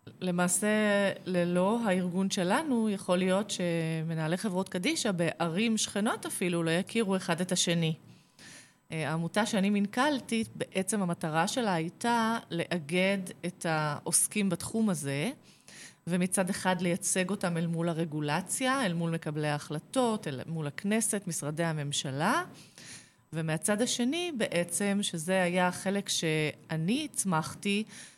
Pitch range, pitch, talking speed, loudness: 165-205 Hz, 180 Hz, 115 wpm, -30 LUFS